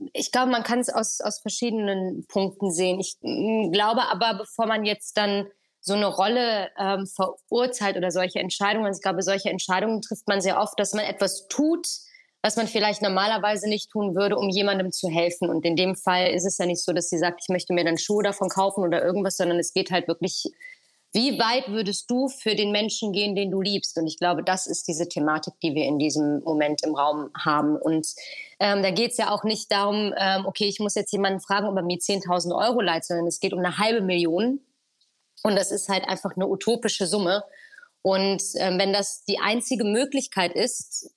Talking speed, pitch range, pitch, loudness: 210 wpm, 185-215 Hz, 195 Hz, -24 LUFS